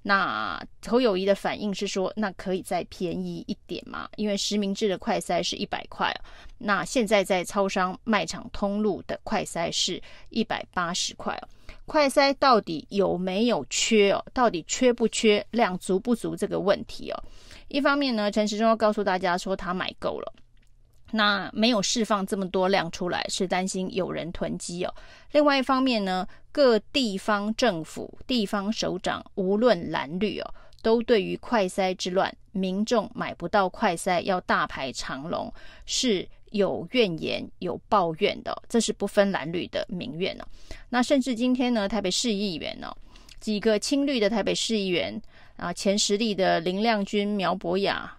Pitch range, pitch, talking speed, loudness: 190-230 Hz, 205 Hz, 250 characters per minute, -26 LUFS